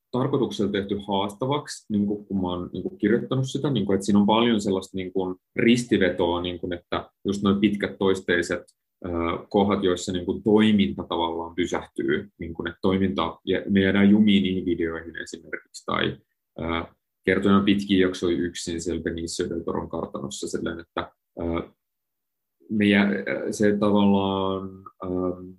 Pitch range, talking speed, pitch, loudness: 90-100 Hz, 145 wpm, 95 Hz, -24 LUFS